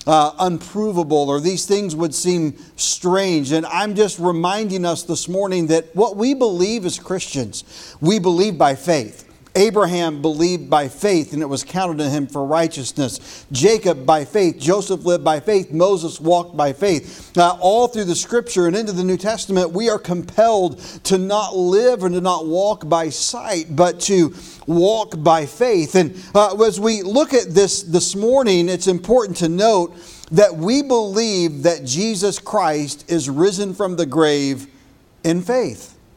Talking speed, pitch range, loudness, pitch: 170 wpm, 160-200 Hz, -18 LUFS, 180 Hz